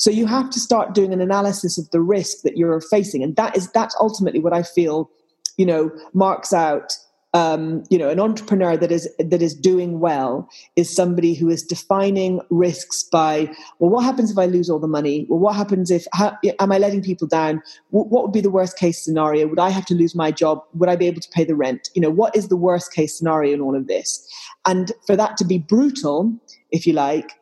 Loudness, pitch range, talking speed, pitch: -19 LUFS, 160-200 Hz, 235 wpm, 180 Hz